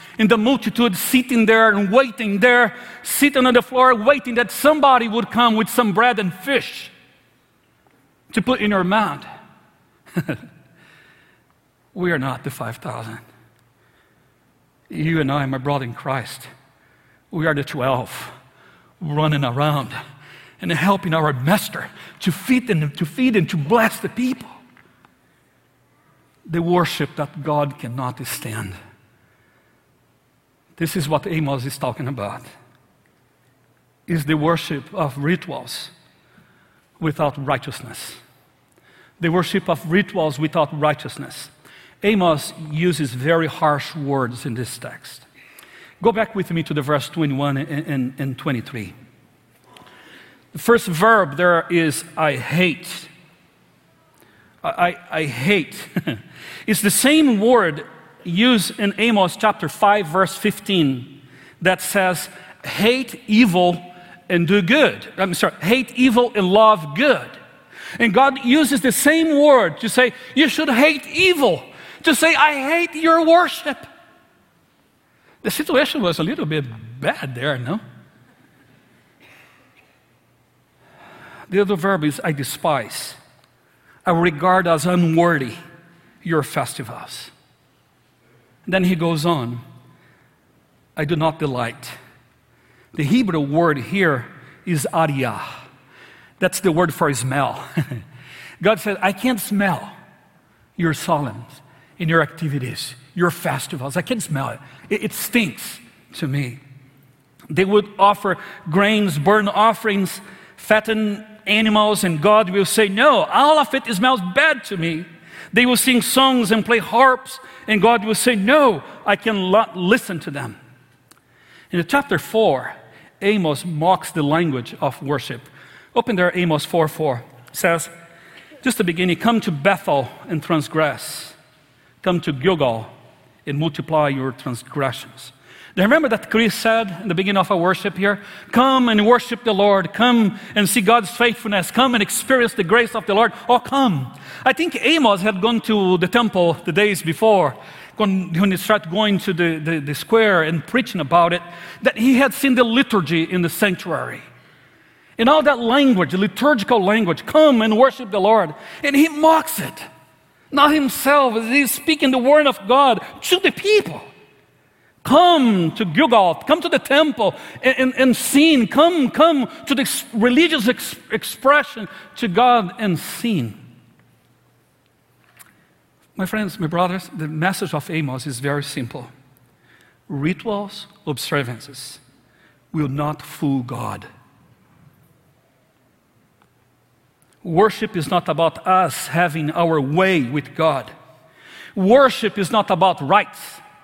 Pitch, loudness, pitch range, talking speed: 180 Hz, -18 LUFS, 150-225 Hz, 135 wpm